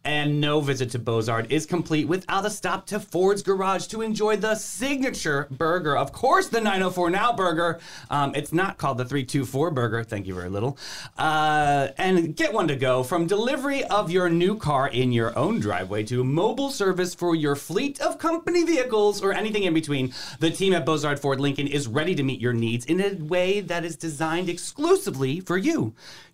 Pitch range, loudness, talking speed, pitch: 140-195 Hz, -24 LUFS, 195 wpm, 165 Hz